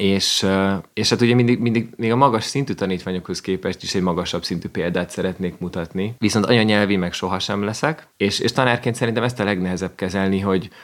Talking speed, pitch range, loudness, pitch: 185 wpm, 95-115 Hz, -20 LUFS, 100 Hz